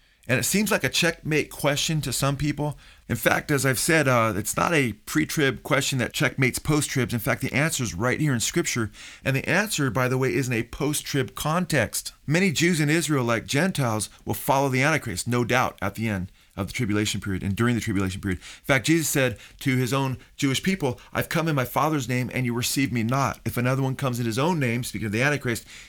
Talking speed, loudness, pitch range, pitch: 235 wpm, -24 LUFS, 115-150 Hz, 130 Hz